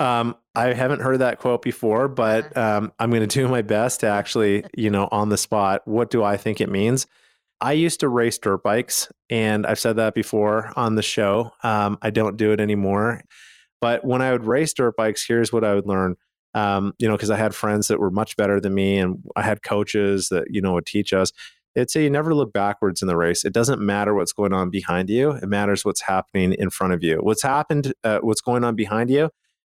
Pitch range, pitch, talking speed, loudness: 100-120 Hz, 110 Hz, 235 wpm, -21 LUFS